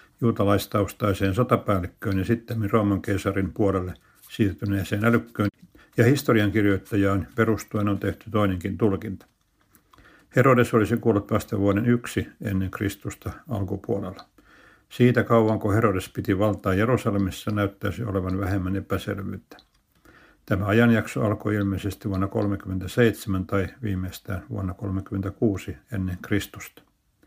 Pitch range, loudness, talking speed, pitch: 95-110 Hz, -24 LUFS, 105 wpm, 100 Hz